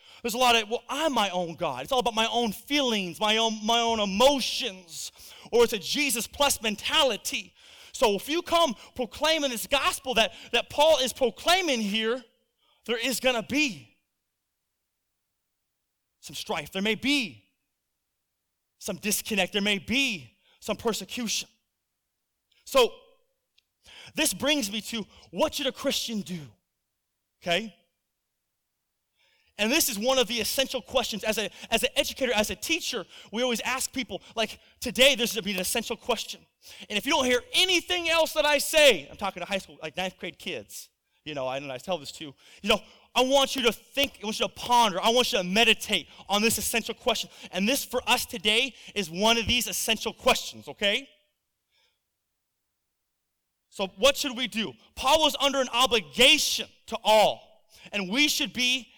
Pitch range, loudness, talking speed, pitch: 200-265 Hz, -25 LUFS, 175 wpm, 230 Hz